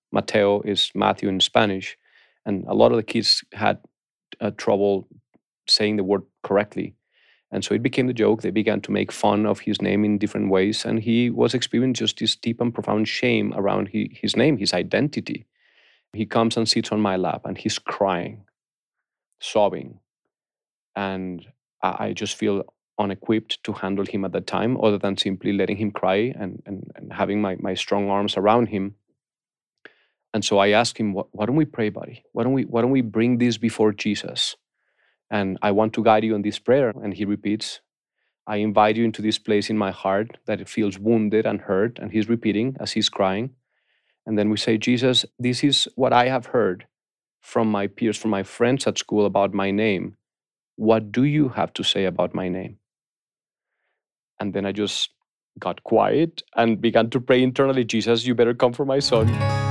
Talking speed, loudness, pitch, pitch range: 195 wpm, -22 LUFS, 105 Hz, 100-115 Hz